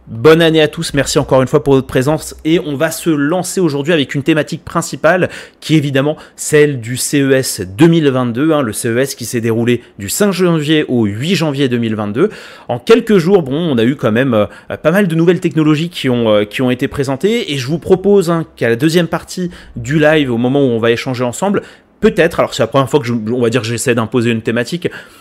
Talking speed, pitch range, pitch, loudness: 230 wpm, 125-165 Hz, 145 Hz, -13 LUFS